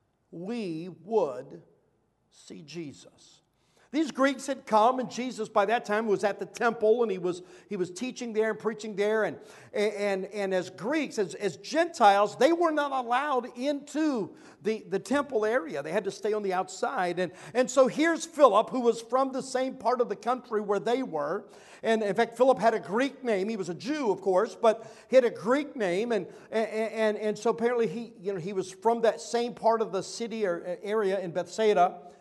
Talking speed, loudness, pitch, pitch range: 205 wpm, -28 LUFS, 220 Hz, 200-245 Hz